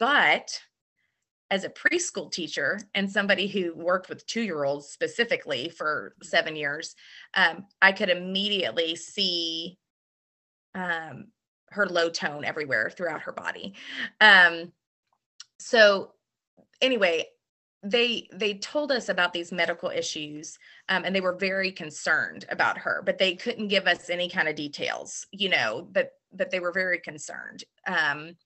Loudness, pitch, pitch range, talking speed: -25 LUFS, 185 Hz, 170-210 Hz, 135 wpm